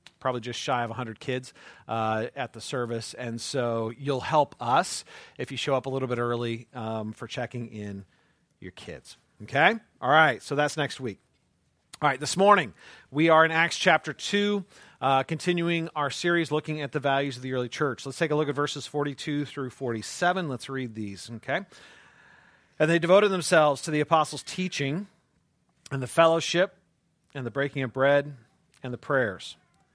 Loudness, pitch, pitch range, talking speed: -26 LUFS, 140 Hz, 125-160 Hz, 180 wpm